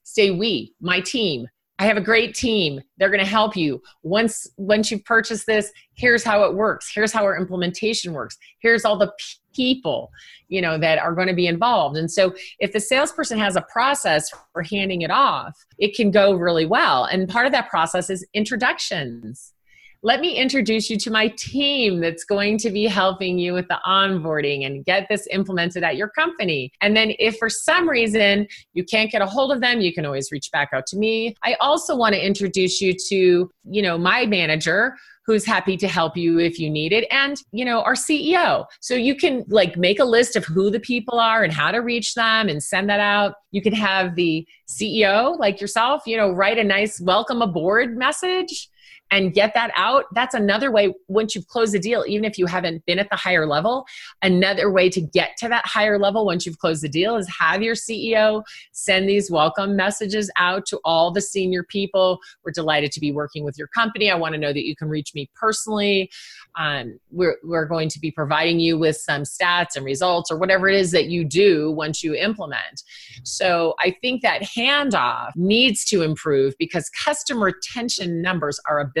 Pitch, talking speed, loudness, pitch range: 200 Hz, 205 wpm, -20 LUFS, 175-225 Hz